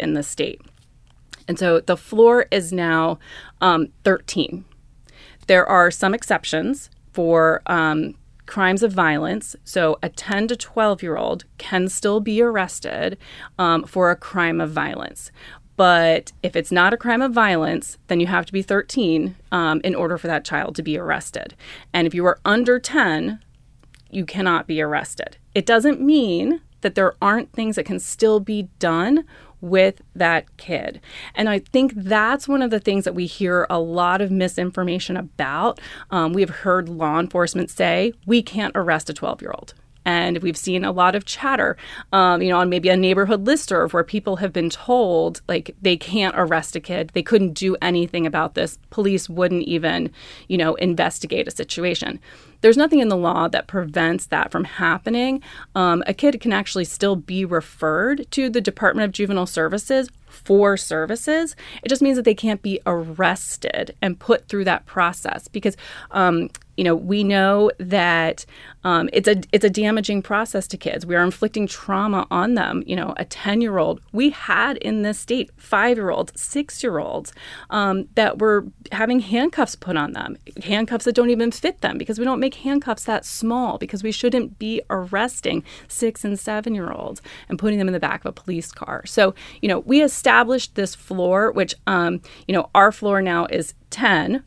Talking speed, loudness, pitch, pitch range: 185 wpm, -20 LUFS, 190 Hz, 175-220 Hz